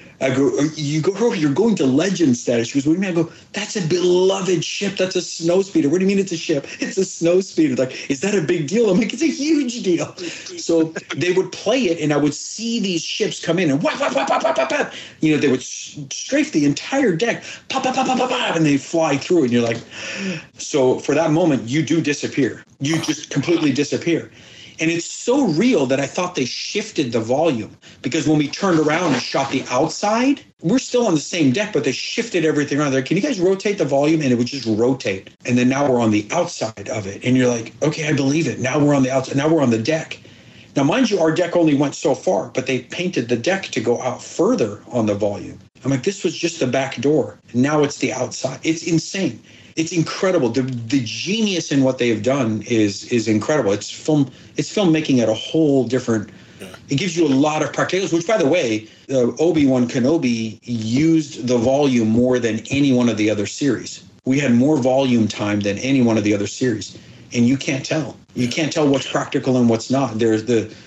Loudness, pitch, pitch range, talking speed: -19 LUFS, 145 Hz, 125-175 Hz, 225 wpm